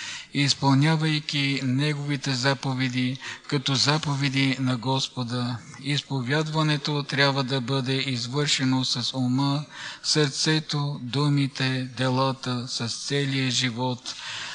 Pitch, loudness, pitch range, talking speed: 135 Hz, -25 LUFS, 130-145 Hz, 80 wpm